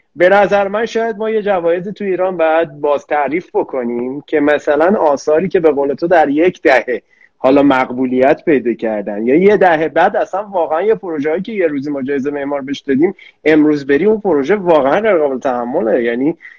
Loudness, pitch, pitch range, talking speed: -14 LUFS, 160 Hz, 140-195 Hz, 185 wpm